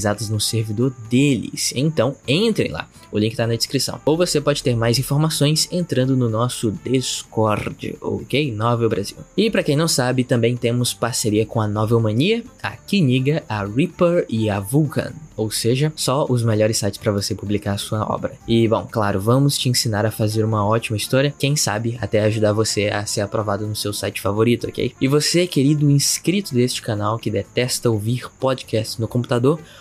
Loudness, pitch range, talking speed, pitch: -20 LUFS, 110-140 Hz, 185 wpm, 115 Hz